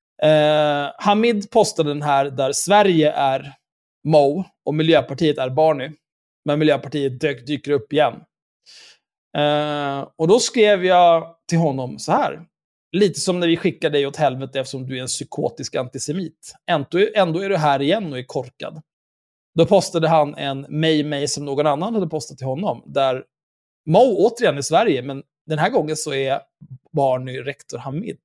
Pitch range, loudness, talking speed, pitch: 140-165 Hz, -19 LUFS, 165 wpm, 150 Hz